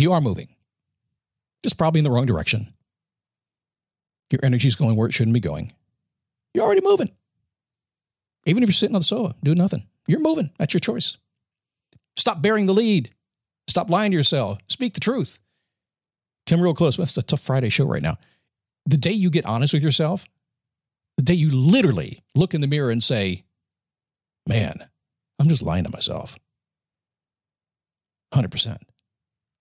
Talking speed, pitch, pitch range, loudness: 165 wpm, 155 Hz, 130-175 Hz, -20 LUFS